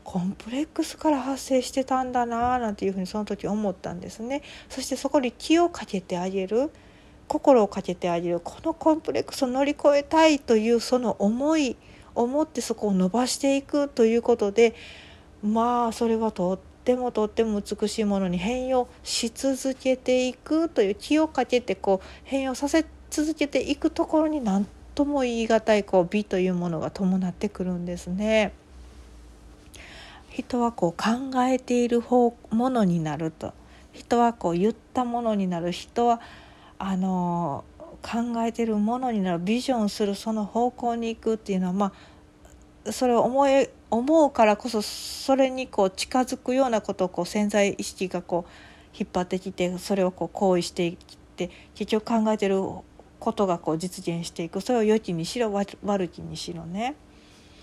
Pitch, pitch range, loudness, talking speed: 225 Hz, 190-255 Hz, -25 LUFS, 335 characters per minute